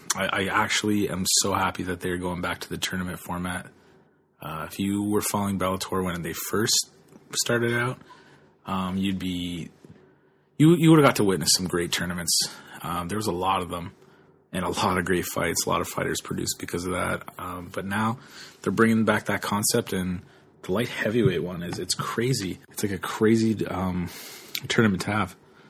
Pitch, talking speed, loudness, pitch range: 95 Hz, 190 wpm, -25 LUFS, 90-110 Hz